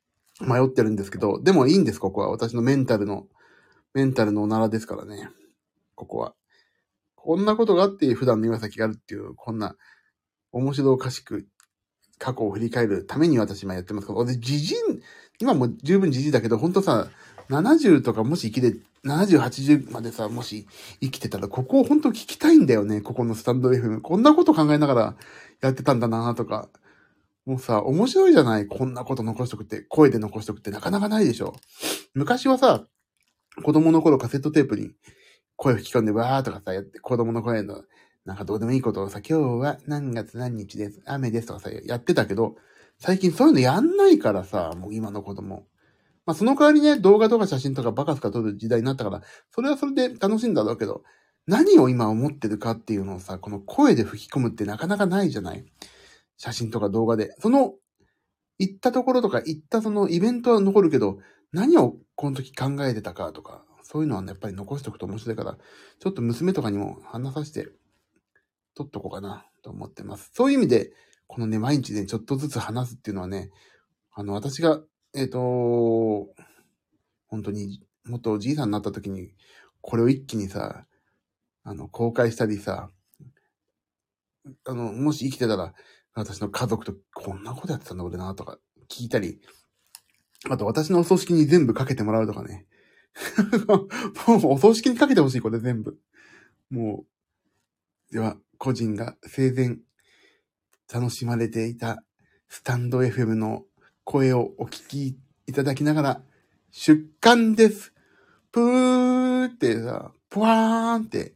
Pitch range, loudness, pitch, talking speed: 110-160 Hz, -23 LUFS, 125 Hz, 350 characters per minute